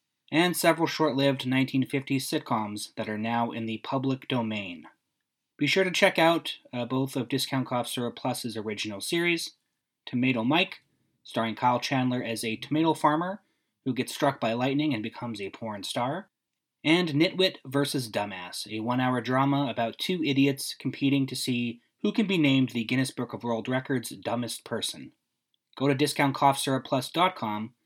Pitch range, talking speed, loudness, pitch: 120-145 Hz, 155 wpm, -27 LUFS, 130 Hz